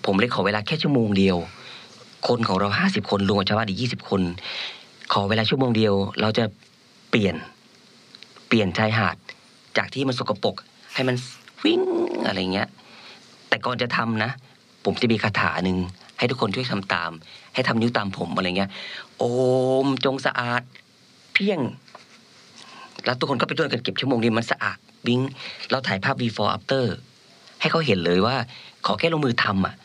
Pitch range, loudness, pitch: 100-130 Hz, -23 LUFS, 115 Hz